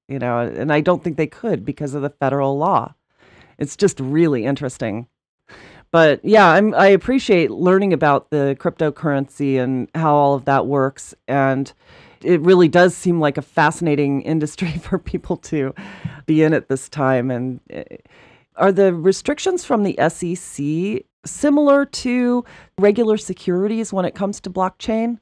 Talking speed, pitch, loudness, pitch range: 155 wpm, 165 Hz, -18 LUFS, 140-195 Hz